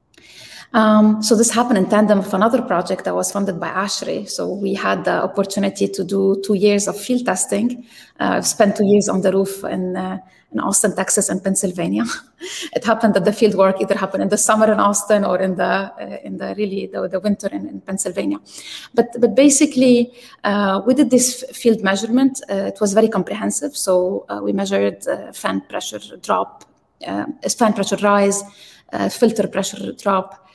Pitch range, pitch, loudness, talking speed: 190-225 Hz, 205 Hz, -18 LUFS, 195 wpm